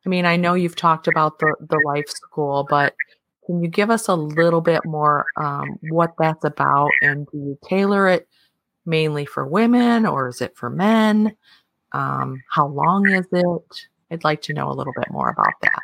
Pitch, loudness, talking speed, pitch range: 165 Hz, -19 LUFS, 195 wpm, 150-185 Hz